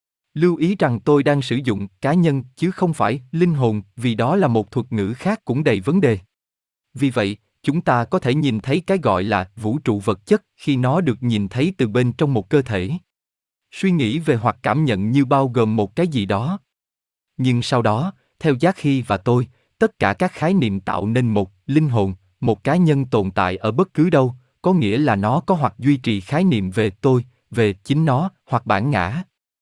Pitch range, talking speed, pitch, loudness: 105-155 Hz, 220 wpm, 125 Hz, -19 LUFS